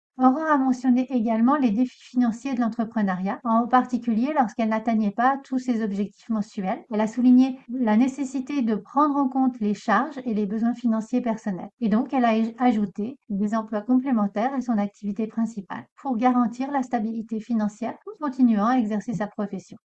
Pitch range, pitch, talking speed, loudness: 215-255 Hz, 235 Hz, 175 wpm, -24 LUFS